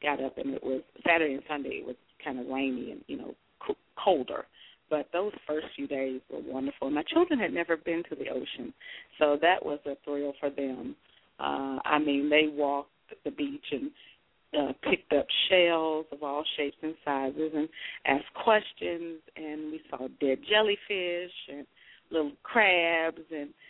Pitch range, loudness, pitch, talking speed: 140-170 Hz, -30 LUFS, 150 Hz, 170 wpm